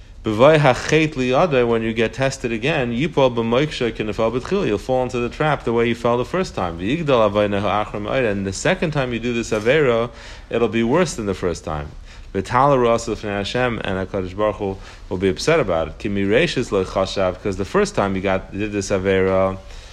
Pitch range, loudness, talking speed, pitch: 95-125 Hz, -19 LUFS, 150 wpm, 110 Hz